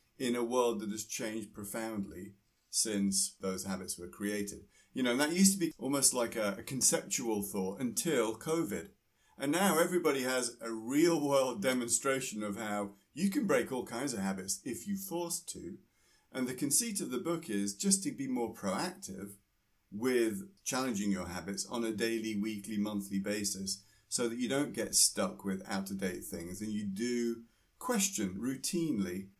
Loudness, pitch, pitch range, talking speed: -34 LUFS, 110 Hz, 100-135 Hz, 175 wpm